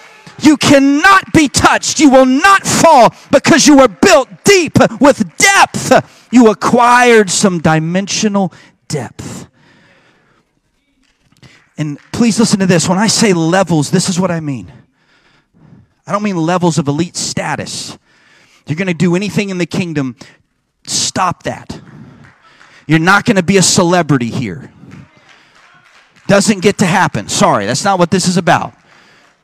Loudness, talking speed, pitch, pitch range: -10 LUFS, 145 wpm, 195 Hz, 170-240 Hz